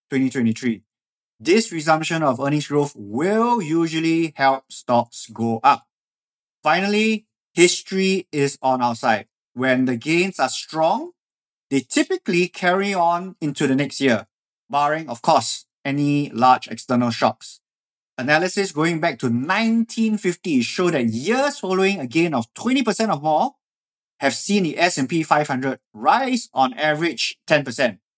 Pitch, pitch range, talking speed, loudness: 155 Hz, 130-190 Hz, 130 wpm, -20 LUFS